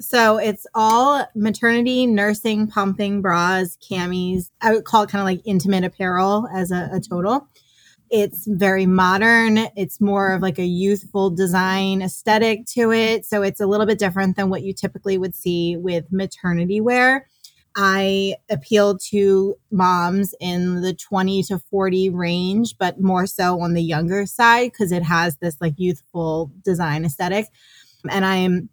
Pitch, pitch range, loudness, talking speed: 195 Hz, 180-210 Hz, -19 LUFS, 160 wpm